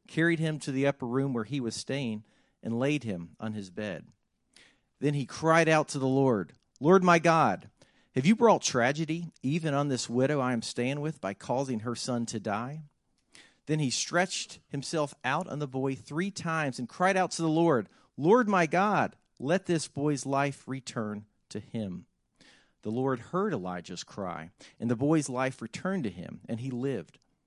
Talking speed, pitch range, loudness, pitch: 185 wpm, 120-160 Hz, -29 LUFS, 140 Hz